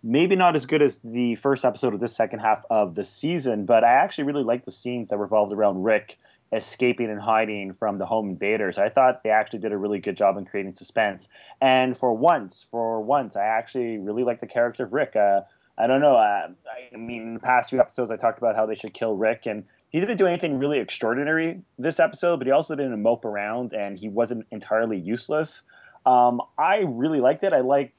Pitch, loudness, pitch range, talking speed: 120 Hz, -23 LUFS, 110-135 Hz, 225 wpm